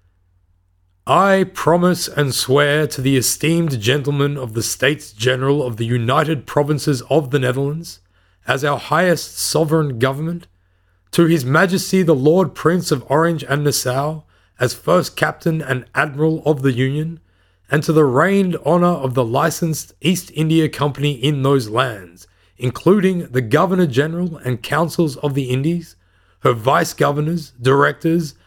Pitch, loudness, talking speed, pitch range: 145 Hz, -17 LUFS, 145 wpm, 125-160 Hz